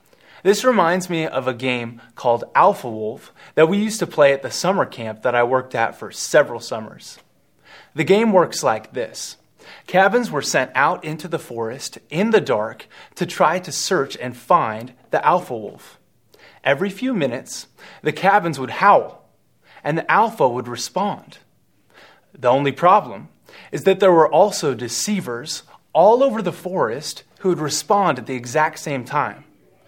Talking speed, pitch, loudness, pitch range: 165 wpm, 155 Hz, -19 LUFS, 125-185 Hz